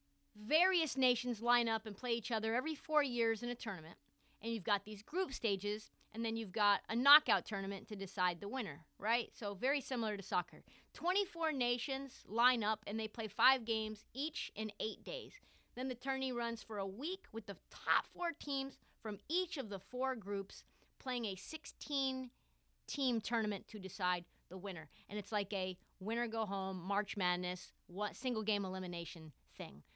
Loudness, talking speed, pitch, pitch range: -38 LUFS, 180 wpm, 225 Hz, 200-255 Hz